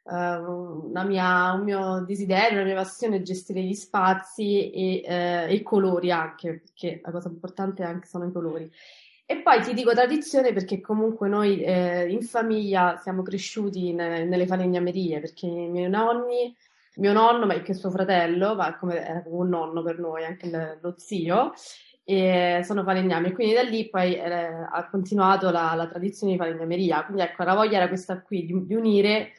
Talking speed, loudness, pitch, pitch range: 180 wpm, -25 LUFS, 185 Hz, 175-200 Hz